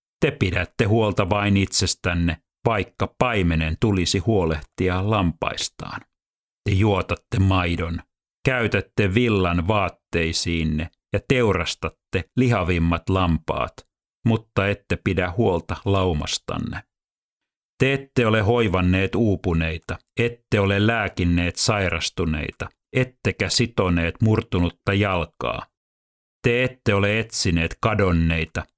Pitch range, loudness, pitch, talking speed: 85-110 Hz, -22 LUFS, 95 Hz, 90 wpm